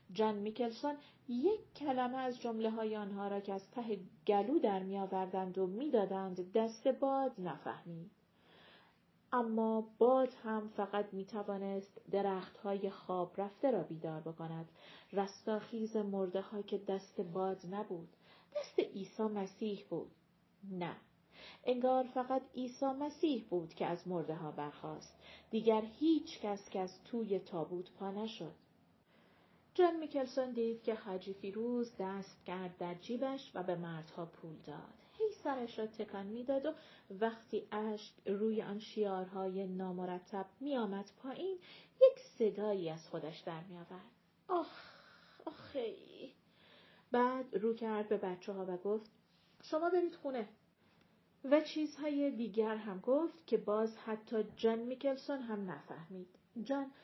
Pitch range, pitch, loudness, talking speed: 190-250 Hz, 210 Hz, -39 LUFS, 130 wpm